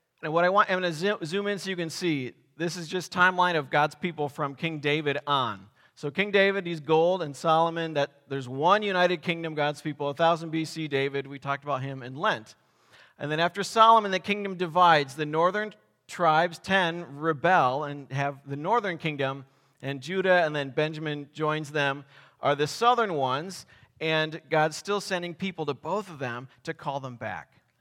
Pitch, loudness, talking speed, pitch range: 155 Hz, -26 LUFS, 190 wpm, 140-180 Hz